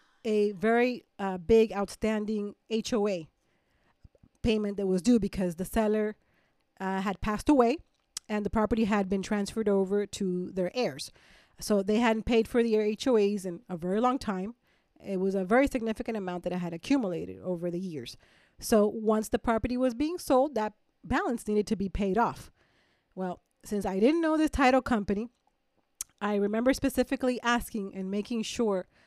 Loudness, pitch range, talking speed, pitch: -29 LUFS, 195-235 Hz, 165 wpm, 215 Hz